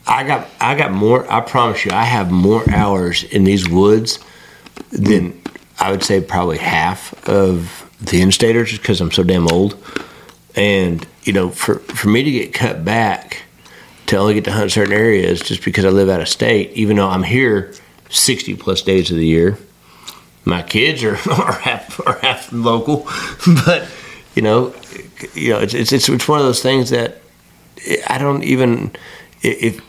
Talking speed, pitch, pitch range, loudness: 175 wpm, 100 Hz, 95-120 Hz, -15 LUFS